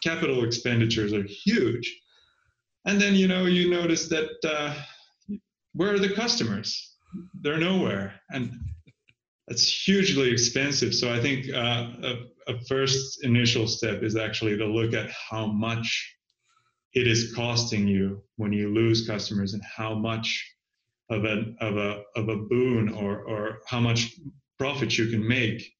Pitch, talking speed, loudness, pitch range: 120 Hz, 150 wpm, -26 LUFS, 110-145 Hz